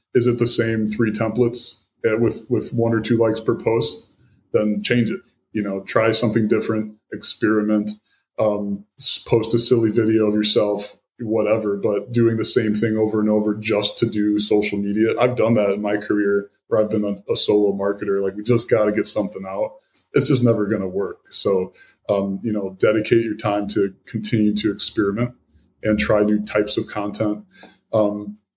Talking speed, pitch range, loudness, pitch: 185 wpm, 105-115 Hz, -20 LUFS, 105 Hz